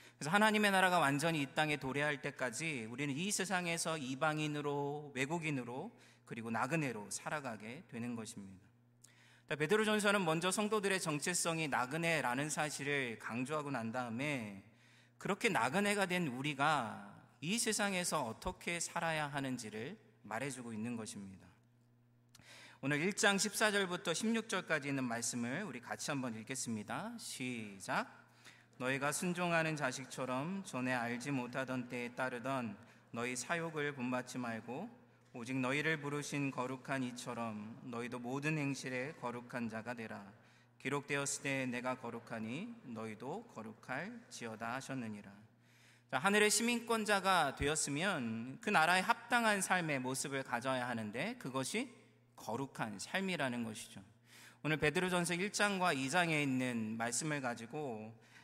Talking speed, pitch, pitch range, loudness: 310 characters per minute, 135 Hz, 120-170 Hz, -37 LUFS